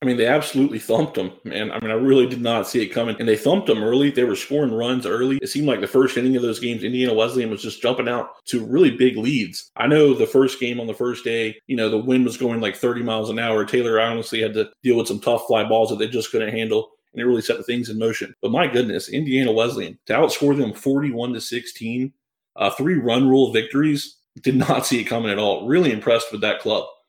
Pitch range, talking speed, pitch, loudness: 115-135 Hz, 255 wpm, 125 Hz, -20 LUFS